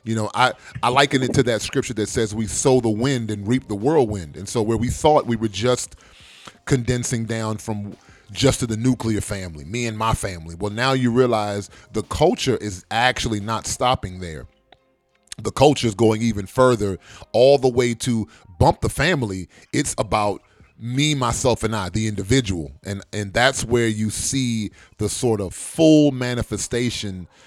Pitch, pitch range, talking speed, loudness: 115 Hz, 105-125 Hz, 180 wpm, -21 LUFS